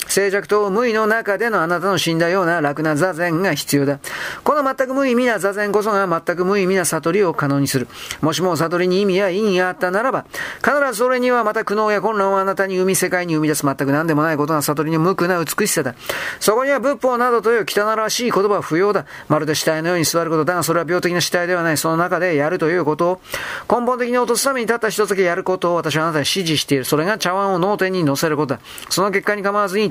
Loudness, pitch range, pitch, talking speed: -18 LUFS, 160-210 Hz, 185 Hz, 475 characters per minute